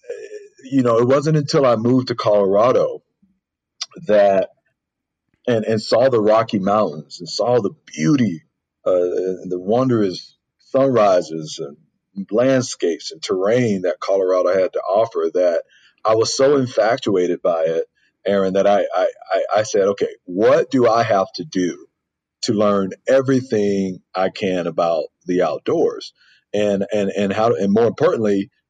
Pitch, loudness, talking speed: 120 Hz, -18 LUFS, 145 wpm